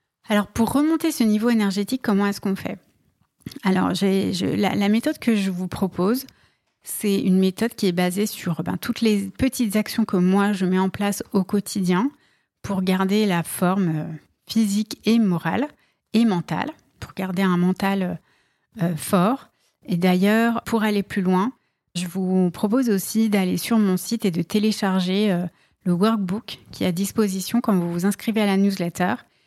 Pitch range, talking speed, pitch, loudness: 185-220 Hz, 170 wpm, 200 Hz, -22 LUFS